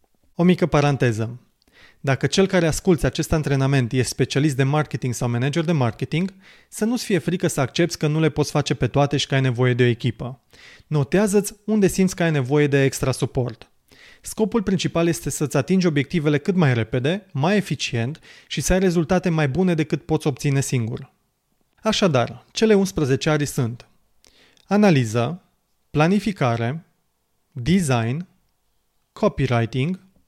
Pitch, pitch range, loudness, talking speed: 150 Hz, 130-180 Hz, -21 LUFS, 150 wpm